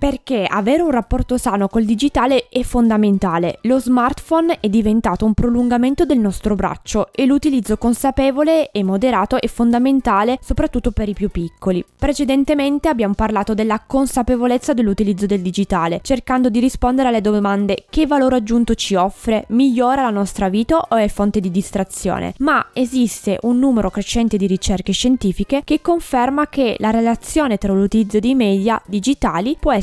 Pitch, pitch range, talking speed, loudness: 235 Hz, 205-260 Hz, 155 wpm, -17 LUFS